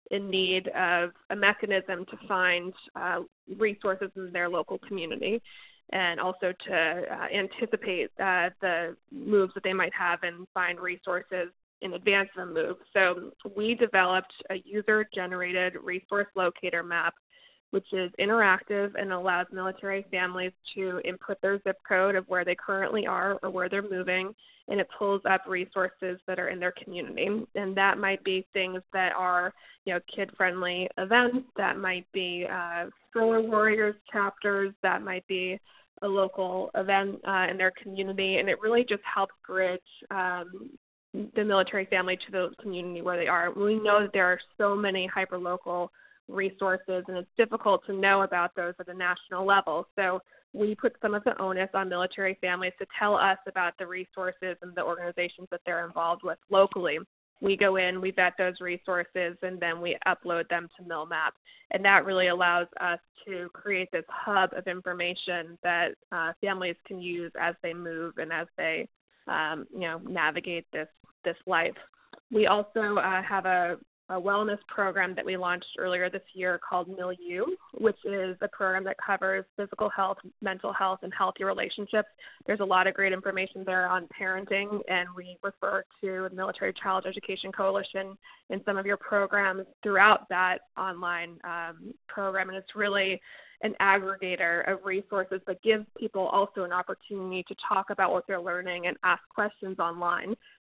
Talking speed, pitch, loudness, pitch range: 170 wpm, 190 Hz, -29 LUFS, 180-200 Hz